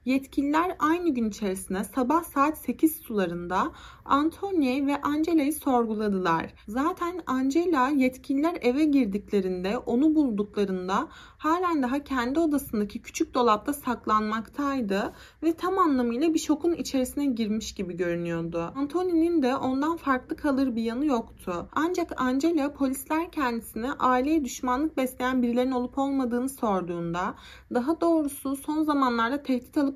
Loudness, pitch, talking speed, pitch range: -27 LUFS, 265 Hz, 120 wpm, 230-310 Hz